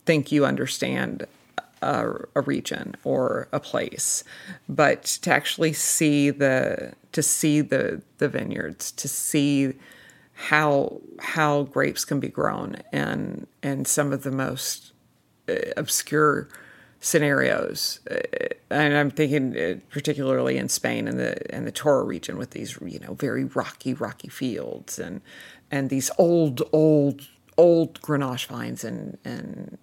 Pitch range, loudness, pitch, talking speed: 130-150 Hz, -24 LUFS, 145 Hz, 130 wpm